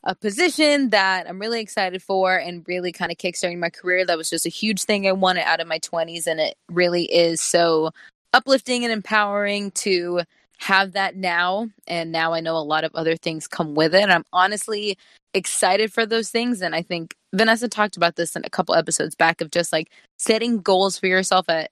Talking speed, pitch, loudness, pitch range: 215 wpm, 185 Hz, -21 LUFS, 170-210 Hz